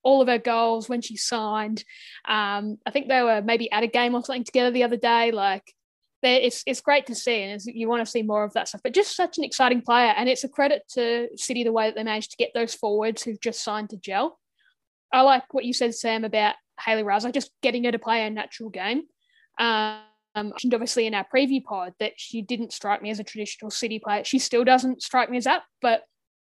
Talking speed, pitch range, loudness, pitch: 240 wpm, 215-255 Hz, -24 LUFS, 235 Hz